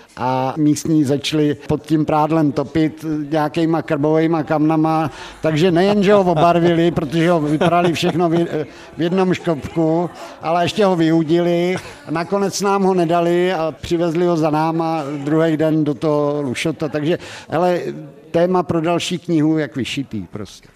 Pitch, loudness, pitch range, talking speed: 160 Hz, -17 LUFS, 150-175 Hz, 140 wpm